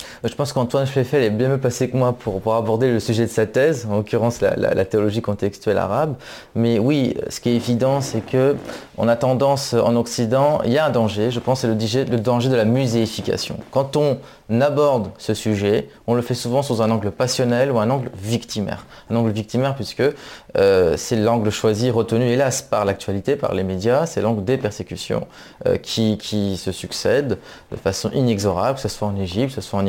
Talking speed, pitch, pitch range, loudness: 210 wpm, 115 Hz, 110-130 Hz, -20 LUFS